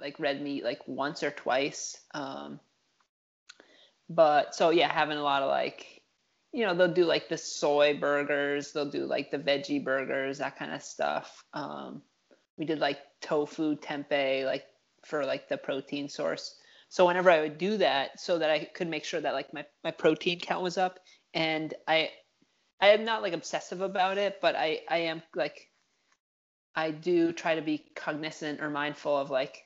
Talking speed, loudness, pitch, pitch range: 180 wpm, -30 LUFS, 155 Hz, 145-170 Hz